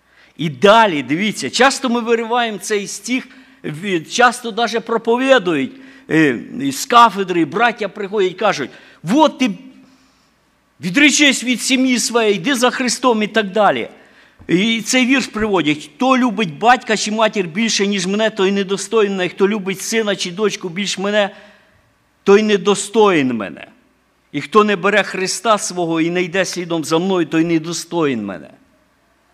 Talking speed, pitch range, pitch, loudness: 140 wpm, 190-245 Hz, 210 Hz, -16 LUFS